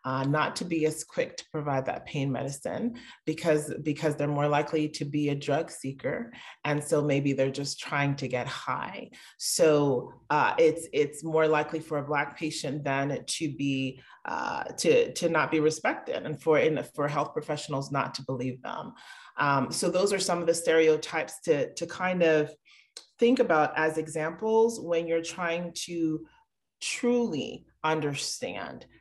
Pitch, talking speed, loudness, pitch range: 155 Hz, 170 wpm, -28 LUFS, 145-170 Hz